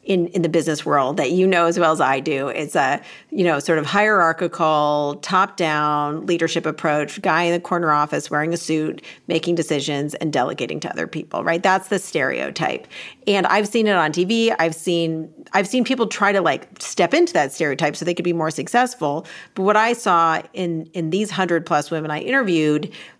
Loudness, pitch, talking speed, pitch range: -20 LUFS, 170 Hz, 205 wpm, 155-190 Hz